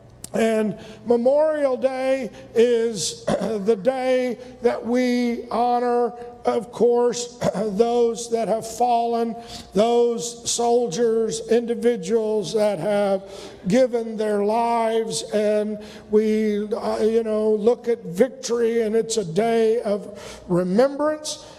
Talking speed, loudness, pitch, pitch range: 100 wpm, -22 LUFS, 230 Hz, 215-240 Hz